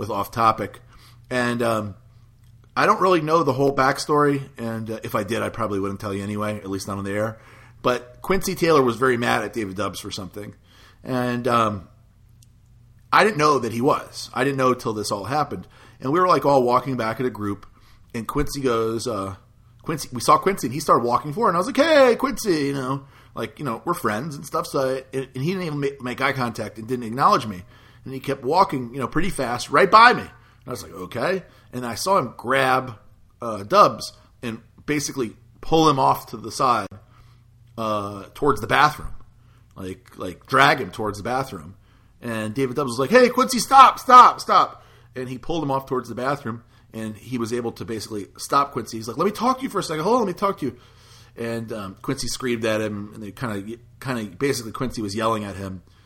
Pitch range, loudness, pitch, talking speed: 110-135 Hz, -21 LUFS, 120 Hz, 225 wpm